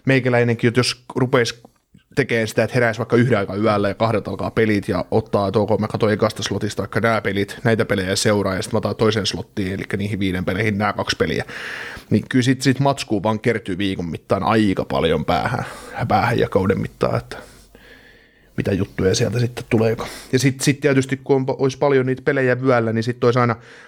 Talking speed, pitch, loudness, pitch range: 200 wpm, 115 Hz, -20 LUFS, 100-125 Hz